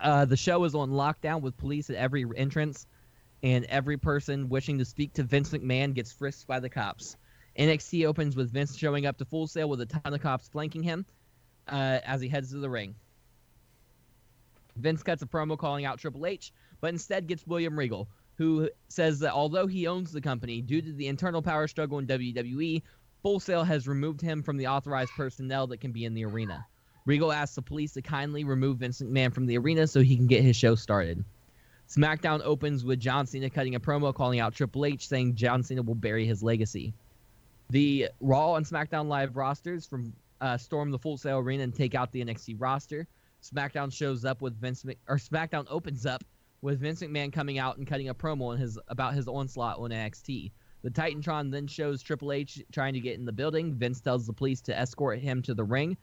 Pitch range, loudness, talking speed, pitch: 125-150 Hz, -30 LUFS, 210 wpm, 135 Hz